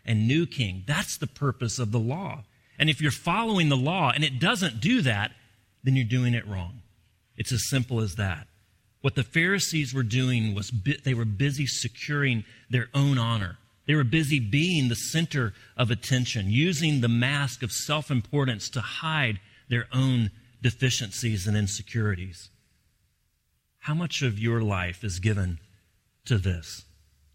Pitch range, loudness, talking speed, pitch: 105-140 Hz, -26 LUFS, 160 wpm, 120 Hz